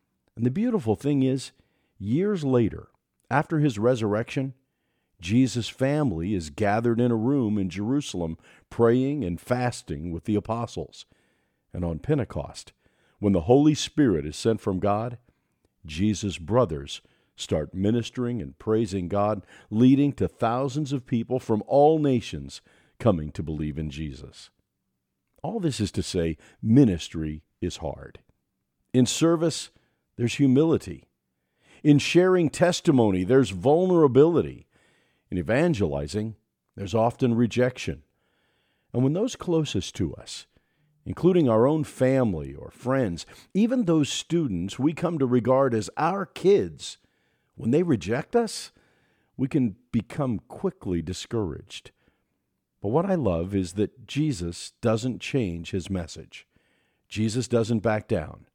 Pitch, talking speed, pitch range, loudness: 120 Hz, 125 wpm, 95-140 Hz, -25 LUFS